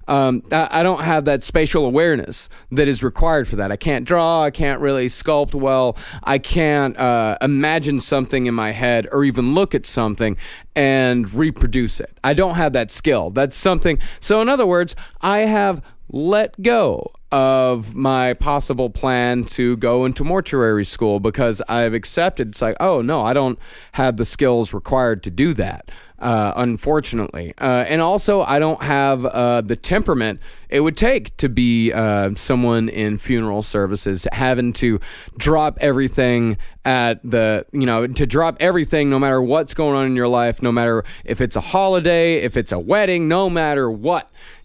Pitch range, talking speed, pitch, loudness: 120-155 Hz, 175 wpm, 130 Hz, -18 LUFS